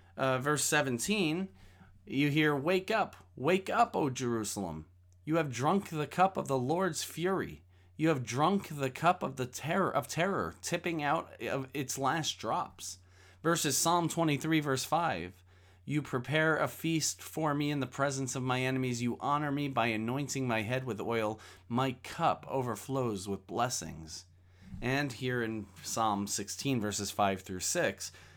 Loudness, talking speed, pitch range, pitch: -32 LUFS, 160 wpm, 100-150 Hz, 130 Hz